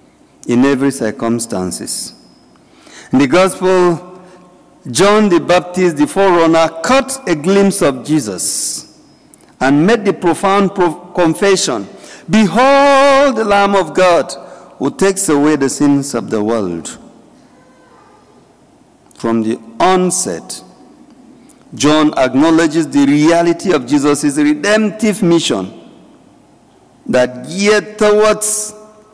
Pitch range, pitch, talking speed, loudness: 145-210 Hz, 180 Hz, 100 wpm, -12 LUFS